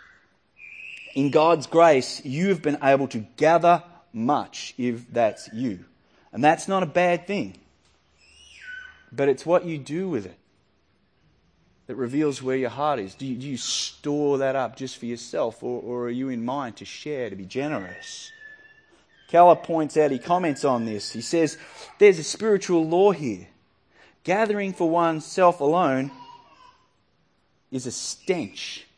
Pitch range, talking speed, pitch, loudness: 130-180 Hz, 155 wpm, 150 Hz, -23 LUFS